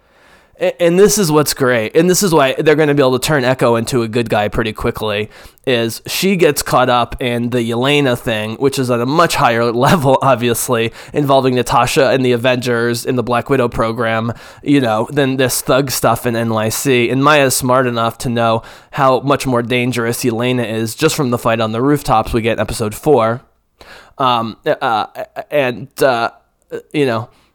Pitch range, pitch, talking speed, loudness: 115-140 Hz, 125 Hz, 190 wpm, -14 LUFS